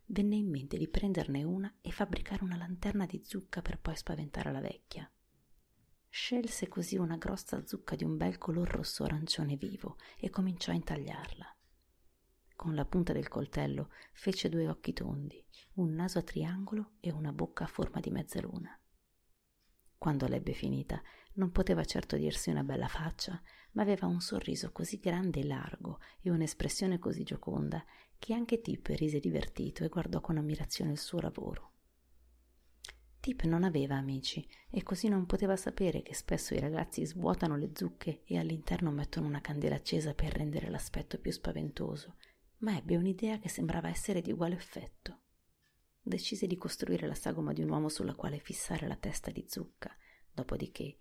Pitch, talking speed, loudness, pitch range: 165 Hz, 160 wpm, -37 LUFS, 135-190 Hz